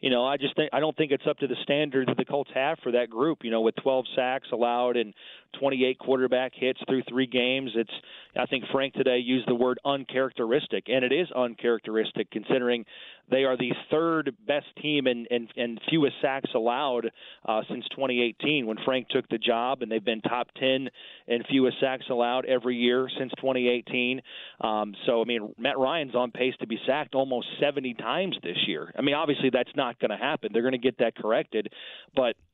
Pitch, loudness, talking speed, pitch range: 130 Hz, -27 LUFS, 200 wpm, 120-135 Hz